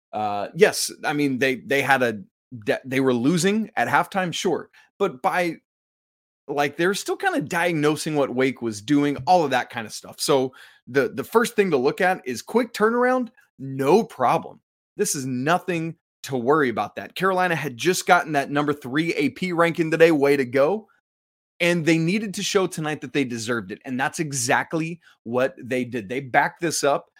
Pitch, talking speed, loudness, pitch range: 155 Hz, 190 wpm, -22 LUFS, 135-180 Hz